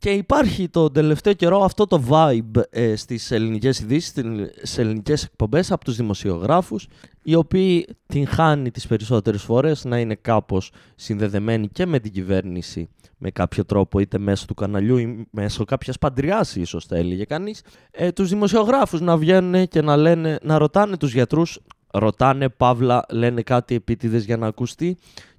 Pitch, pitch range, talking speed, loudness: 125 Hz, 110-165 Hz, 160 wpm, -20 LUFS